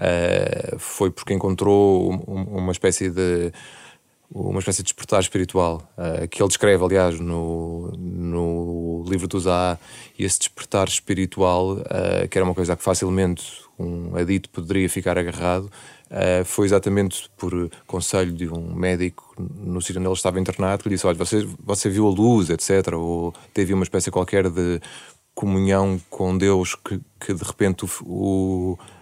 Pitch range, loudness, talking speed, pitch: 90-95 Hz, -22 LUFS, 165 wpm, 95 Hz